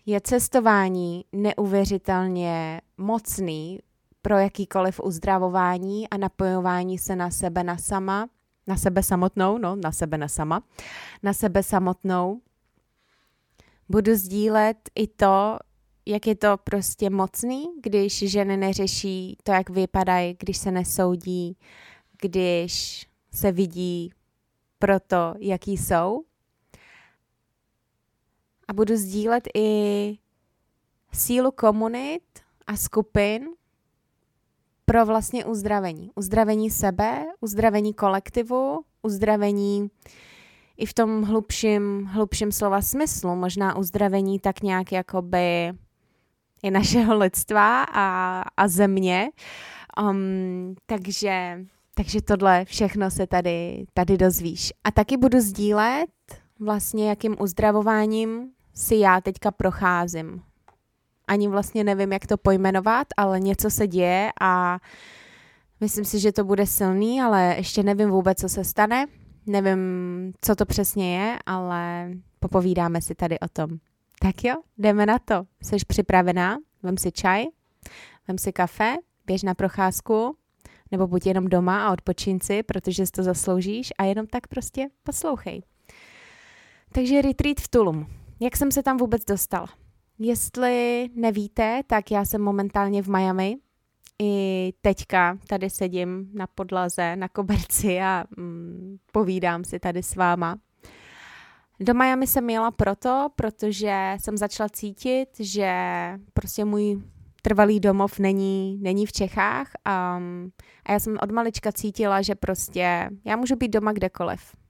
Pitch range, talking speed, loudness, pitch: 185-215 Hz, 125 wpm, -23 LUFS, 195 Hz